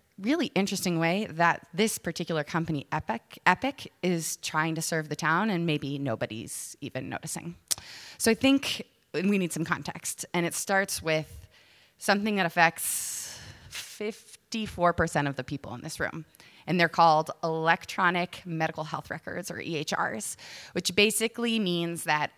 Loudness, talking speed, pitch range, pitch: -28 LUFS, 145 wpm, 160-195 Hz, 170 Hz